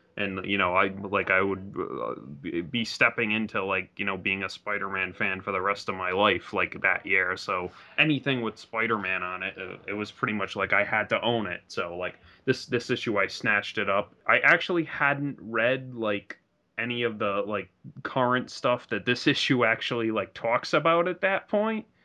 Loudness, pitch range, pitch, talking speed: -27 LUFS, 100-130 Hz, 110 Hz, 195 wpm